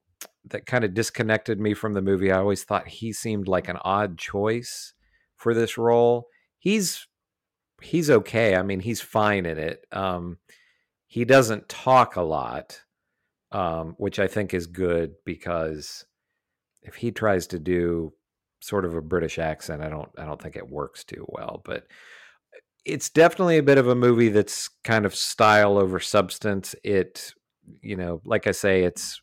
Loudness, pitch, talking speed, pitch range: -23 LUFS, 100 Hz, 170 wpm, 90-115 Hz